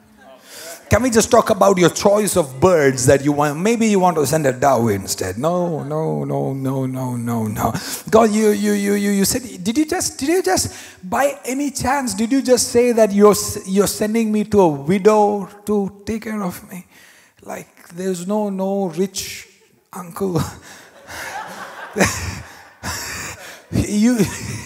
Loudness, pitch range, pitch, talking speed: -18 LUFS, 155-220 Hz, 200 Hz, 160 wpm